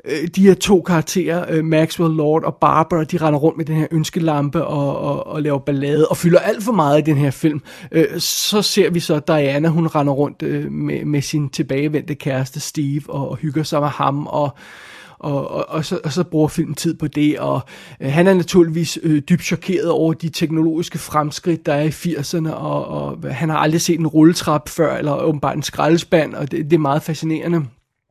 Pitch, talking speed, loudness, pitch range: 155 Hz, 200 wpm, -18 LUFS, 145-165 Hz